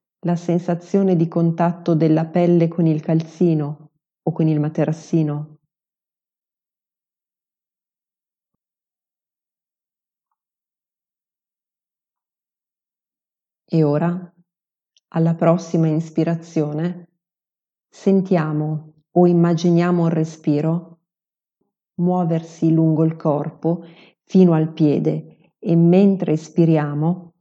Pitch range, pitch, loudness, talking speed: 155-175 Hz, 165 Hz, -19 LUFS, 70 wpm